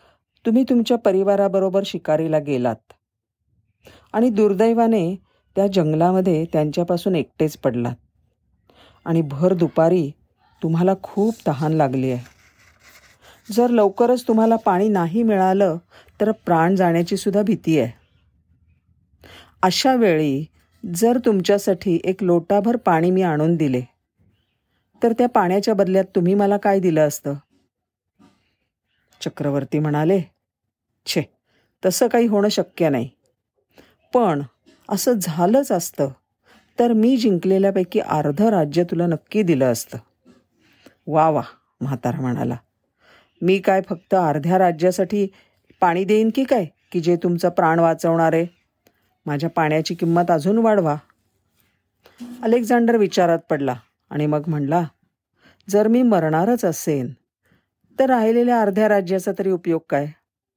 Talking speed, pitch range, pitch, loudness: 110 wpm, 150-205 Hz, 175 Hz, -19 LUFS